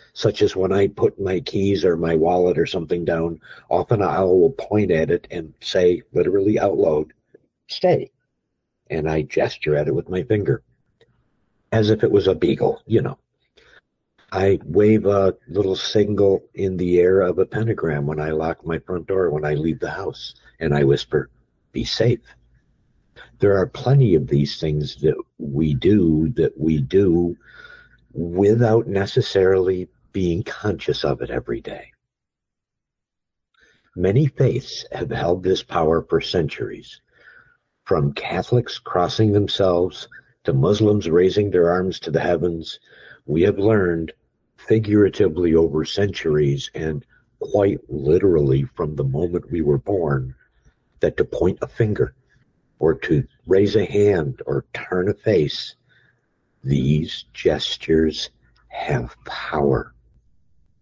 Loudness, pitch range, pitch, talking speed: -20 LUFS, 80-100 Hz, 90 Hz, 140 wpm